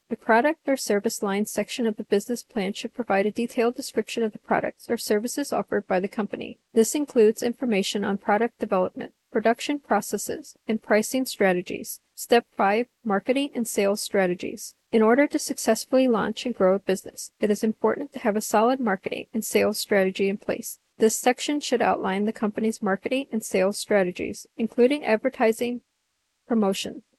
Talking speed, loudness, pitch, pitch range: 170 wpm, -24 LUFS, 225 Hz, 205-245 Hz